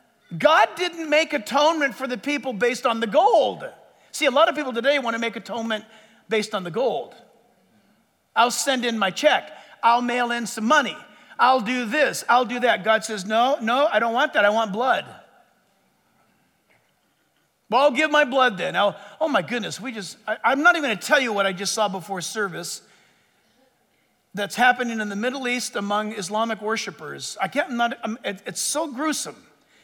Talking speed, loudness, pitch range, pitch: 195 wpm, -22 LUFS, 215-275 Hz, 235 Hz